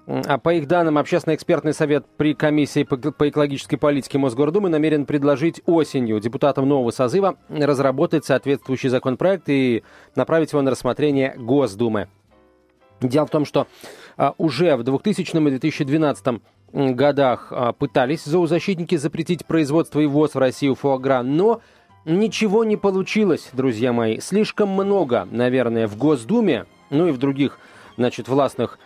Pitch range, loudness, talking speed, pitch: 130-160 Hz, -20 LUFS, 130 wpm, 145 Hz